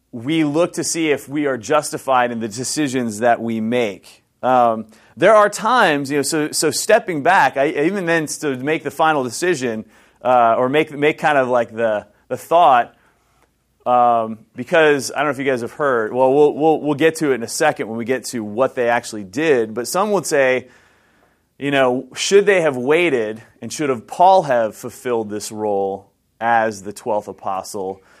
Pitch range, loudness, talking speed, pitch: 115-150 Hz, -17 LUFS, 195 wpm, 130 Hz